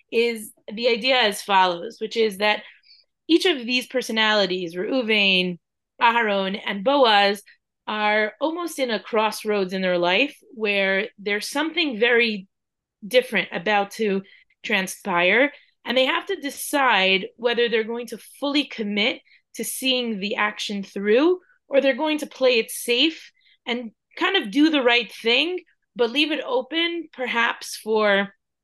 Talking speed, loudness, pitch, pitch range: 140 wpm, -21 LUFS, 235 Hz, 205-280 Hz